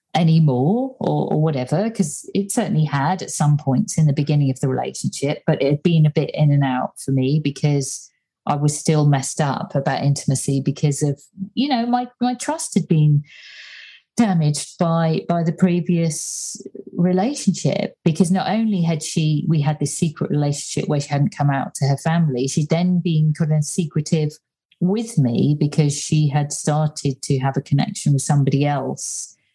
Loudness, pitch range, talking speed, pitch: -20 LUFS, 145-180 Hz, 180 wpm, 155 Hz